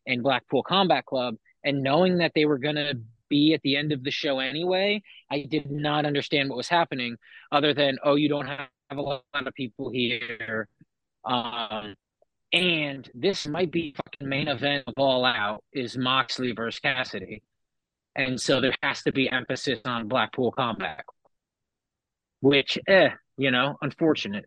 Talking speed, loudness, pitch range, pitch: 160 wpm, -25 LUFS, 125-150 Hz, 140 Hz